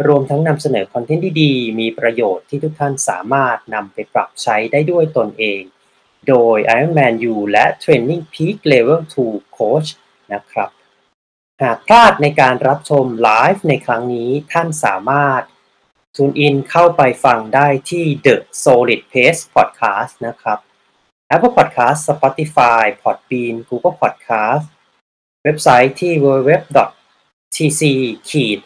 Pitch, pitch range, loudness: 140 Hz, 120-155 Hz, -14 LUFS